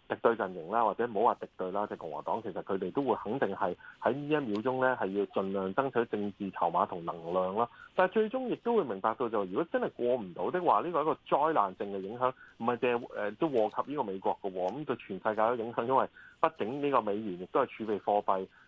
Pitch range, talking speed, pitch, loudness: 100-135 Hz, 365 characters per minute, 115 Hz, -32 LUFS